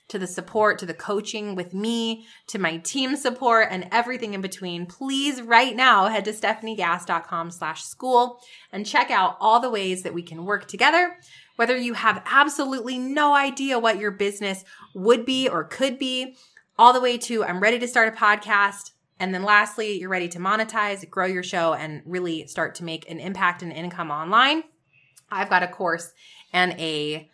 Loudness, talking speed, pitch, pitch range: -22 LUFS, 180 wpm, 205 Hz, 175-240 Hz